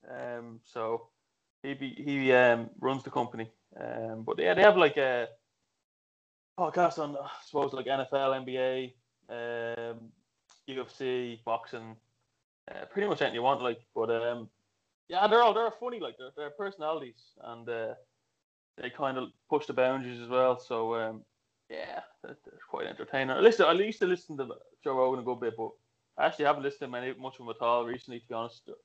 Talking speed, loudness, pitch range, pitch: 185 wpm, -30 LUFS, 115-140 Hz, 130 Hz